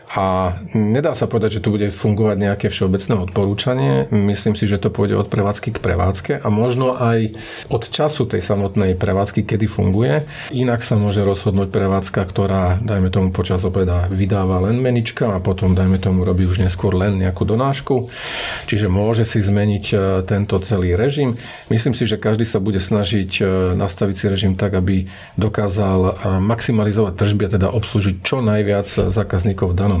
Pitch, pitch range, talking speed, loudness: 105 Hz, 95-110 Hz, 165 wpm, -18 LUFS